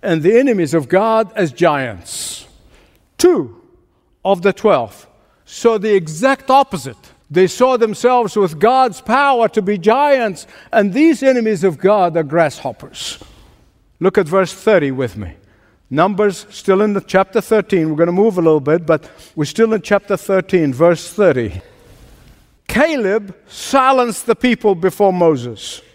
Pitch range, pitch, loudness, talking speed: 165-225 Hz, 195 Hz, -15 LUFS, 150 wpm